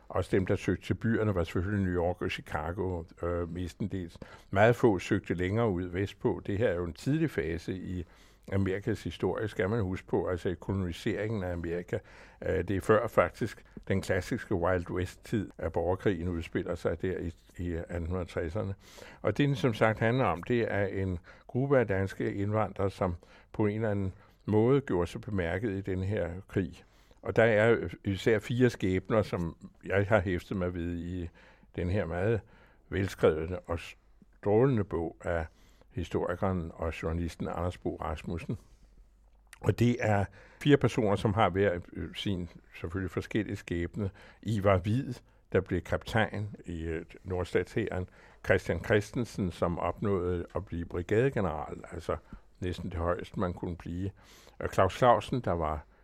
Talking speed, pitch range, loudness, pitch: 155 wpm, 90-105 Hz, -31 LUFS, 95 Hz